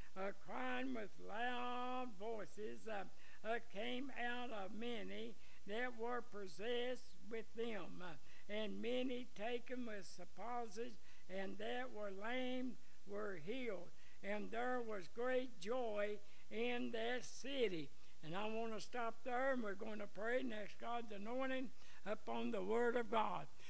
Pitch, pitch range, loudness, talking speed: 230 Hz, 205-245 Hz, -46 LUFS, 140 wpm